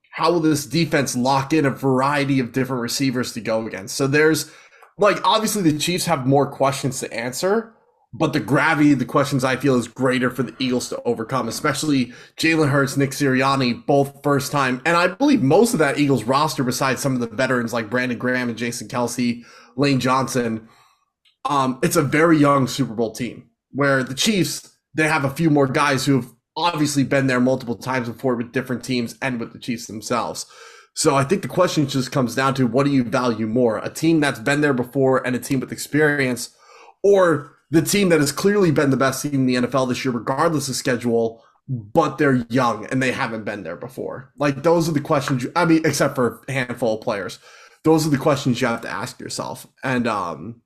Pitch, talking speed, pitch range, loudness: 135 Hz, 210 wpm, 125-150 Hz, -20 LUFS